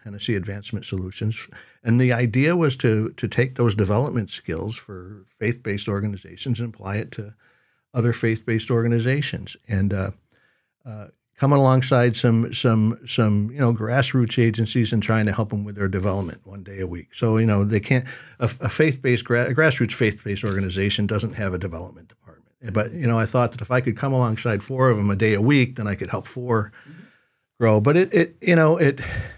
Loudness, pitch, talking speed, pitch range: -22 LUFS, 115 Hz, 195 wpm, 105-125 Hz